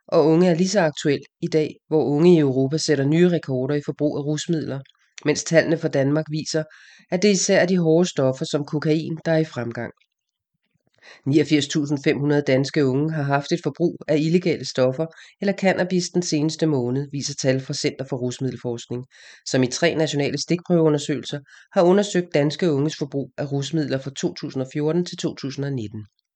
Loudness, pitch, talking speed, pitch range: -22 LUFS, 150 Hz, 170 wpm, 140-165 Hz